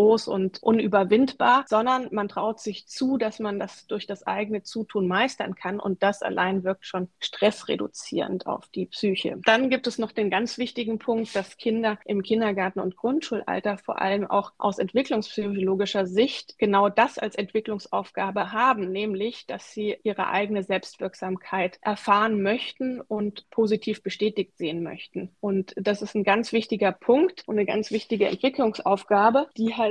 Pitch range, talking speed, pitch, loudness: 195-225 Hz, 155 wpm, 210 Hz, -25 LUFS